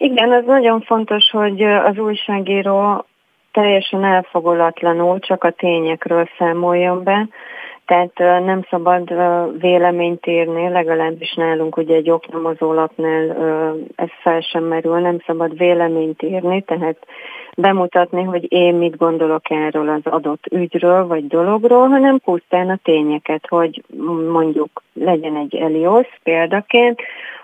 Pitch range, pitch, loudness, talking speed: 165-195 Hz, 175 Hz, -16 LUFS, 120 wpm